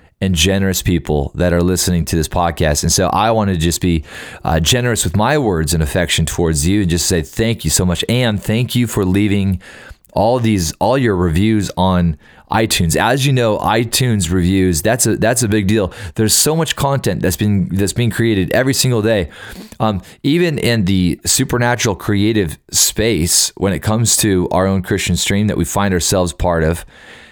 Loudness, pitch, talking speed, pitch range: -15 LUFS, 100 Hz, 195 wpm, 90-115 Hz